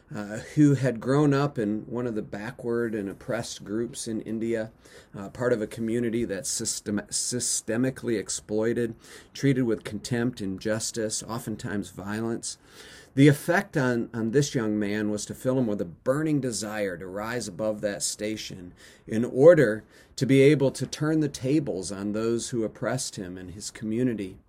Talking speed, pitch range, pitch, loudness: 165 wpm, 105-130 Hz, 115 Hz, -27 LUFS